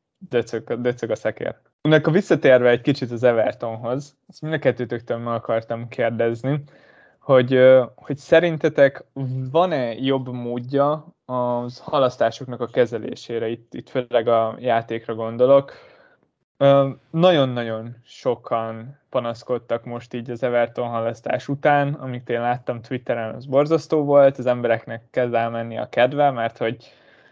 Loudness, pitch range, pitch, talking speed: -21 LUFS, 115-140 Hz, 125 Hz, 120 wpm